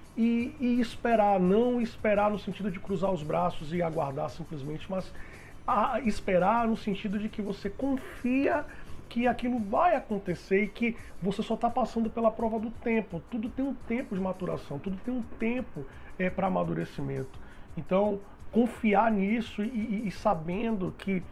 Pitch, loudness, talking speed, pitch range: 210 Hz, -30 LUFS, 165 wpm, 185-230 Hz